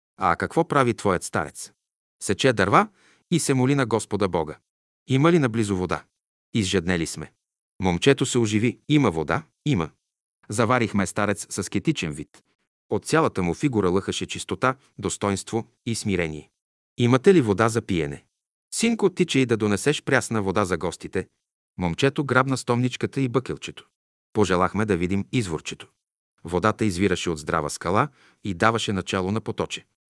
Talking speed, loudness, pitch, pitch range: 145 wpm, -24 LUFS, 110 Hz, 95-130 Hz